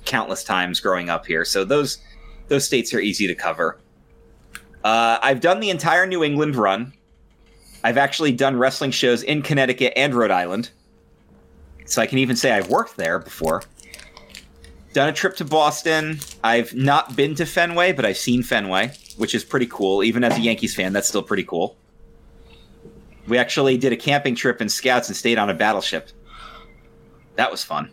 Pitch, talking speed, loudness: 120 Hz, 180 wpm, -20 LUFS